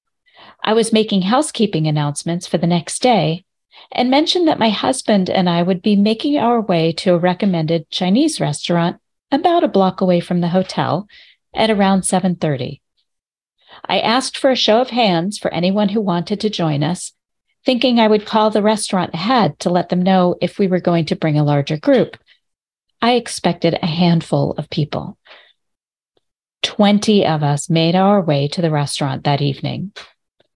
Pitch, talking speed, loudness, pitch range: 185 Hz, 170 wpm, -16 LUFS, 170-220 Hz